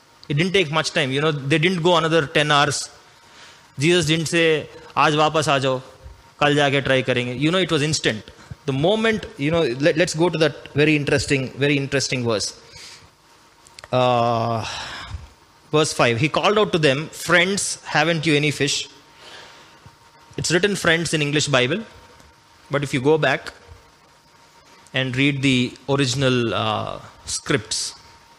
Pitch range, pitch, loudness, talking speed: 135-160 Hz, 150 Hz, -20 LUFS, 145 wpm